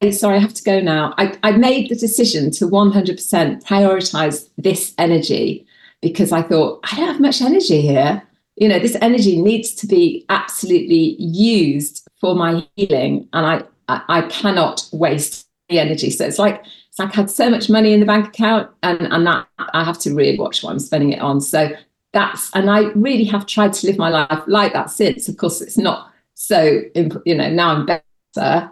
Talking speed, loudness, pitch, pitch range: 200 wpm, -16 LUFS, 195 Hz, 165-215 Hz